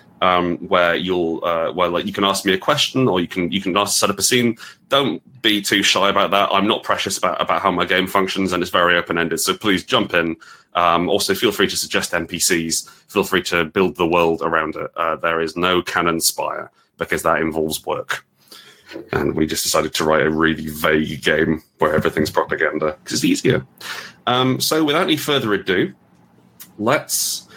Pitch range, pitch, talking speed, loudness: 80-95 Hz, 85 Hz, 205 wpm, -18 LUFS